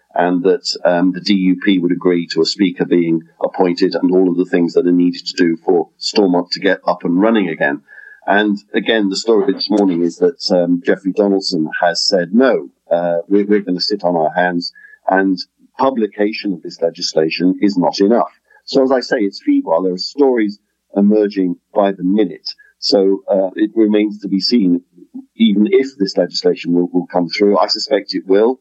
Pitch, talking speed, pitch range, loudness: 95 Hz, 200 wpm, 90-105 Hz, -15 LUFS